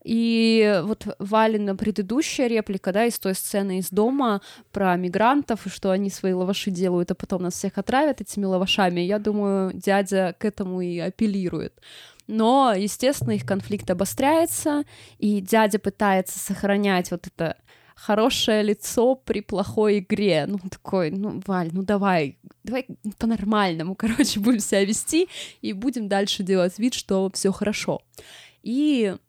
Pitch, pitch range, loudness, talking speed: 205 Hz, 190-225 Hz, -23 LUFS, 145 wpm